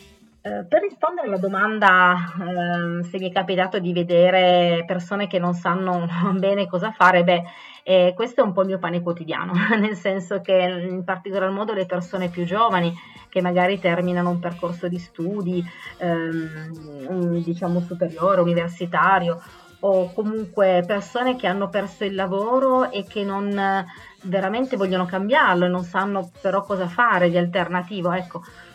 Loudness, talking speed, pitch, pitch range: -21 LUFS, 150 wpm, 185 Hz, 175-195 Hz